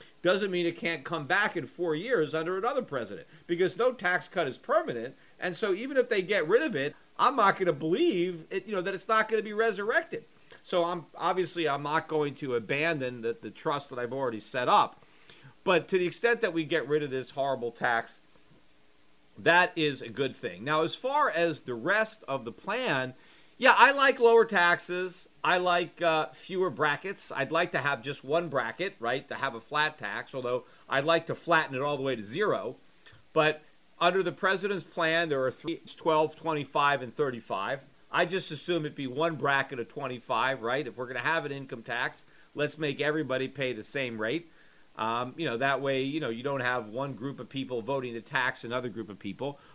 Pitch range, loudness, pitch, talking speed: 130-180 Hz, -29 LUFS, 155 Hz, 210 wpm